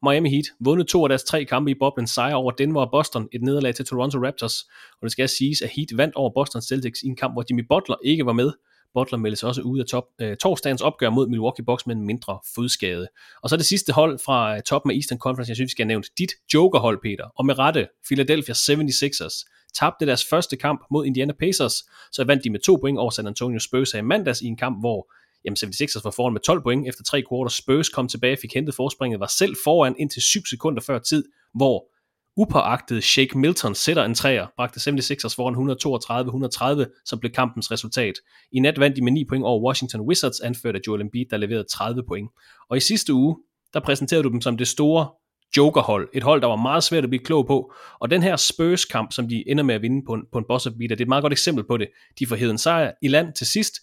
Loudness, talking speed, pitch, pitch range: -22 LUFS, 240 wpm, 130 Hz, 120-145 Hz